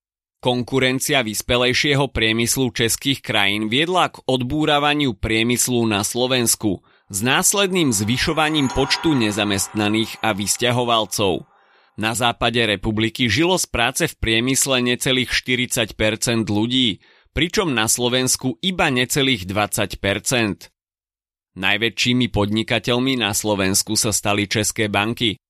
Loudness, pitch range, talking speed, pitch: -19 LUFS, 105-130 Hz, 100 wpm, 115 Hz